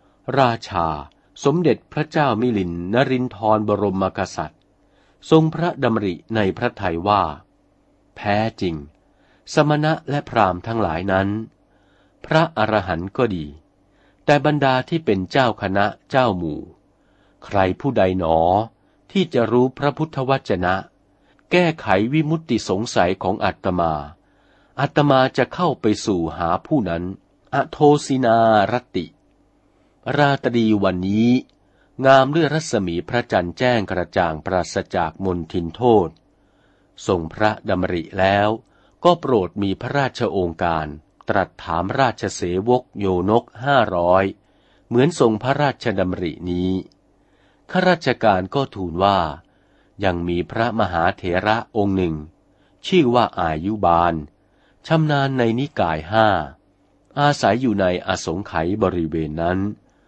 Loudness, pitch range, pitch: -20 LUFS, 90-130 Hz, 105 Hz